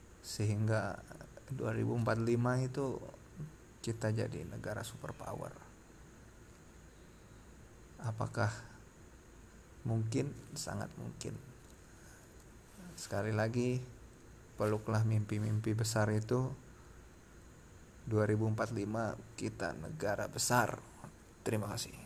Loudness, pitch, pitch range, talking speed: -37 LUFS, 110 Hz, 105-120 Hz, 65 wpm